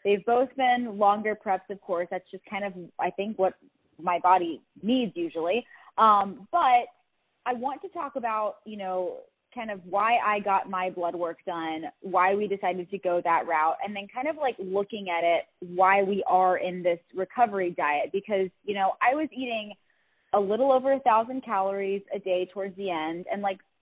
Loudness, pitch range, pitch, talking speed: -27 LUFS, 180-225 Hz, 195 Hz, 195 wpm